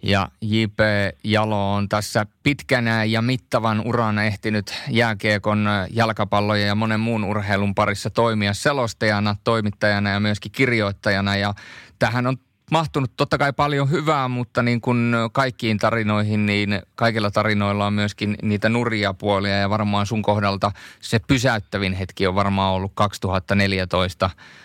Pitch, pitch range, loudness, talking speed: 105 Hz, 100-115 Hz, -21 LUFS, 135 wpm